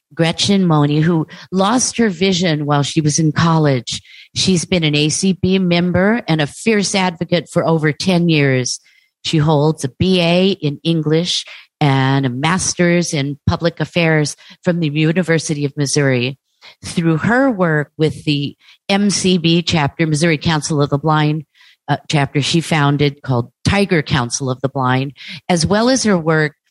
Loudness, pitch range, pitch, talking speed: -16 LUFS, 145-180 Hz, 160 Hz, 155 wpm